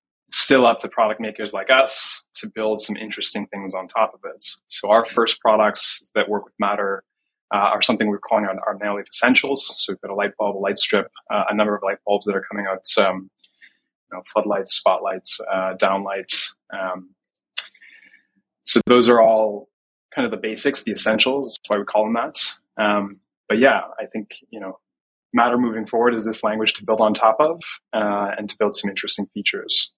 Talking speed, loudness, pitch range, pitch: 200 wpm, -19 LUFS, 100-110 Hz, 105 Hz